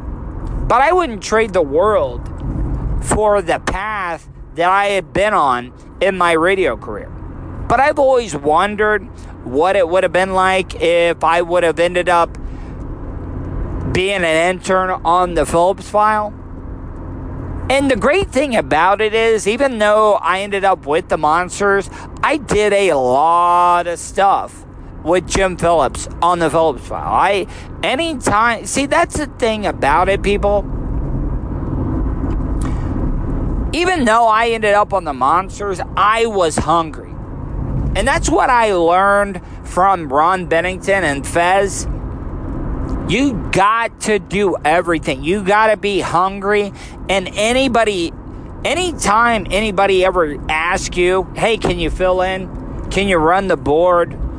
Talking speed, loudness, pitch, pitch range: 140 wpm, -15 LUFS, 185 Hz, 170-210 Hz